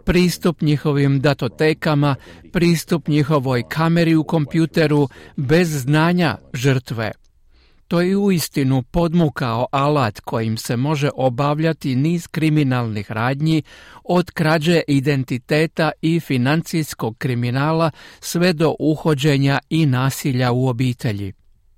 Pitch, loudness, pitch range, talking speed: 150 Hz, -19 LUFS, 130-160 Hz, 100 wpm